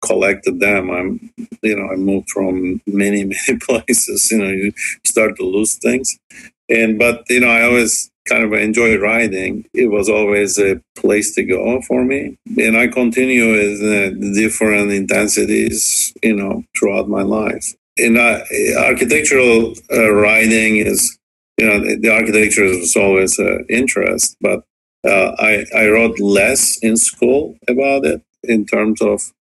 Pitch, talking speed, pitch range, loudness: 110 Hz, 160 wpm, 100-115 Hz, -14 LUFS